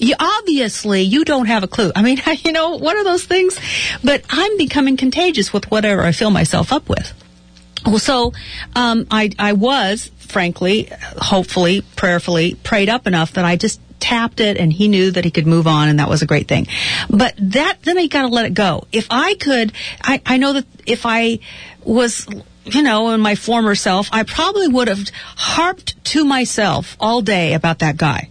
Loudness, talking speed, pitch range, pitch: -15 LUFS, 200 wpm, 190-265 Hz, 220 Hz